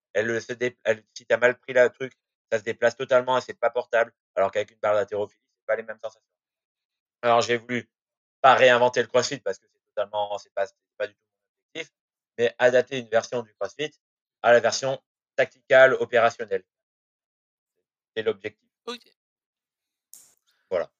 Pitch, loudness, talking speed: 125 Hz, -24 LUFS, 170 wpm